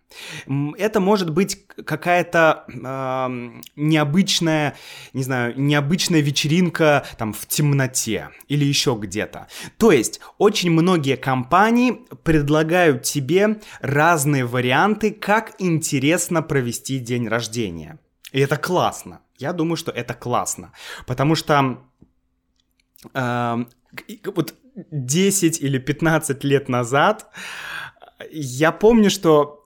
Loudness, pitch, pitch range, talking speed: -19 LUFS, 145 Hz, 130-170 Hz, 100 wpm